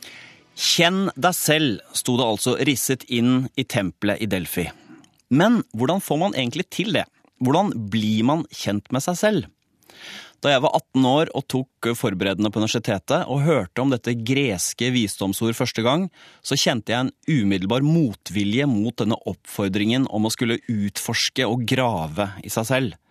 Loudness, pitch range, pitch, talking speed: -22 LUFS, 105-135 Hz, 125 Hz, 160 wpm